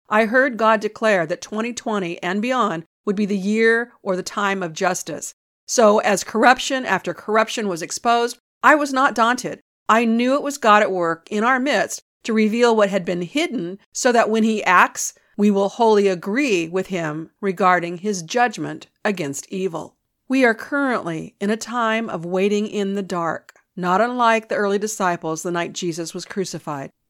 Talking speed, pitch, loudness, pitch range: 180 wpm, 210 Hz, -20 LUFS, 180-230 Hz